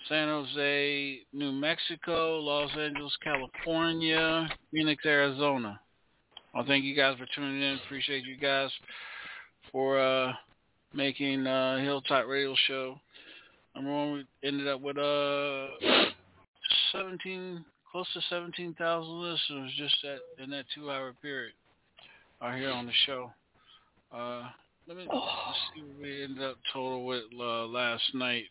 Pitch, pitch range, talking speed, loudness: 140 Hz, 130-150 Hz, 135 wpm, -30 LUFS